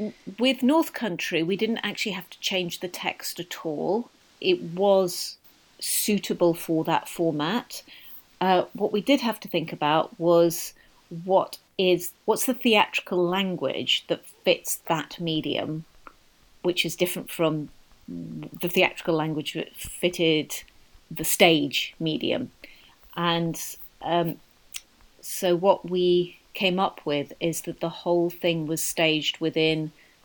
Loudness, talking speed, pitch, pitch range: -25 LUFS, 130 wpm, 175 Hz, 160-195 Hz